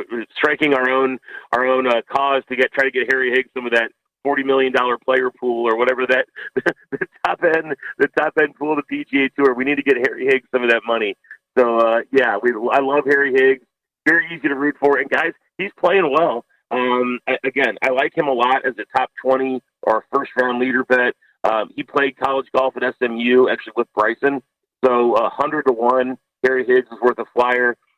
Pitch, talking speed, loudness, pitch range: 130 Hz, 215 wpm, -18 LUFS, 125-140 Hz